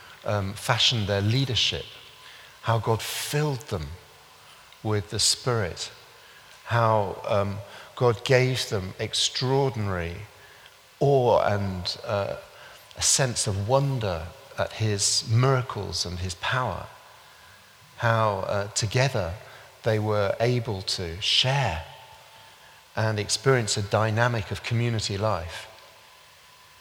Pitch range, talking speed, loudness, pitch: 100-120 Hz, 100 wpm, -25 LUFS, 110 Hz